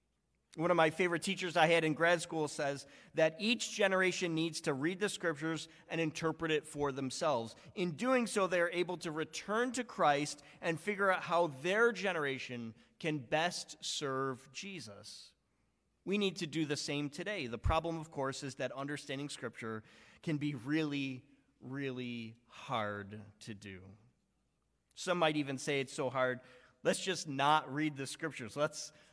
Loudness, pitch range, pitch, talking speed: -36 LUFS, 135-170 Hz, 155 Hz, 165 wpm